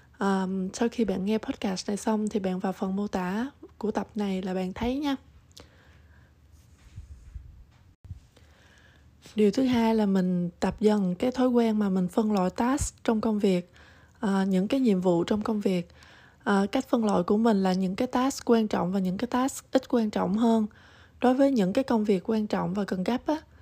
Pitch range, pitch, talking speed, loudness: 190-240 Hz, 215 Hz, 200 wpm, -27 LUFS